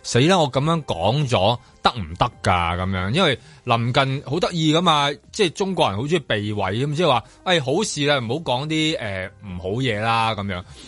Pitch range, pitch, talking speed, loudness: 105-155 Hz, 130 Hz, 285 characters per minute, -21 LUFS